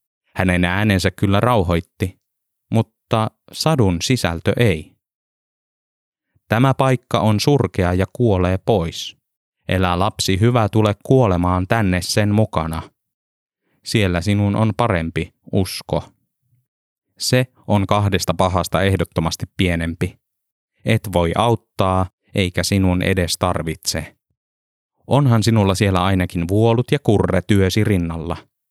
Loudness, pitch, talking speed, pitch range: -18 LUFS, 100 Hz, 105 wpm, 90-115 Hz